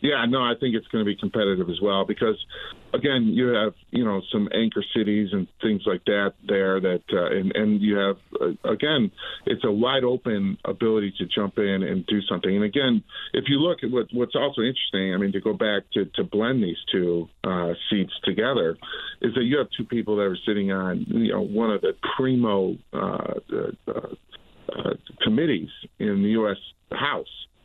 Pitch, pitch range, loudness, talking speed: 105 Hz, 95-120 Hz, -24 LUFS, 200 wpm